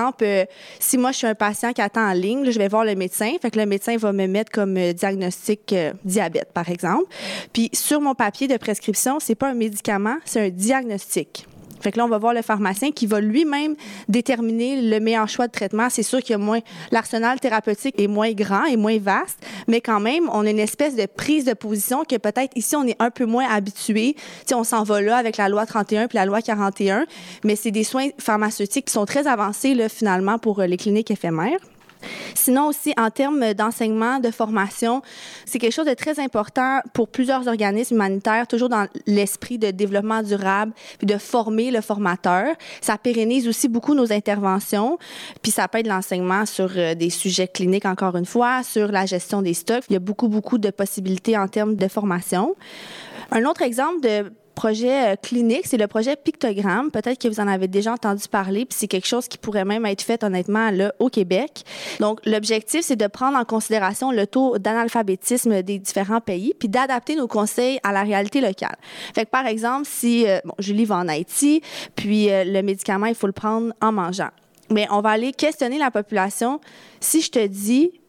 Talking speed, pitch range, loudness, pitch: 205 wpm, 205-245 Hz, -21 LUFS, 220 Hz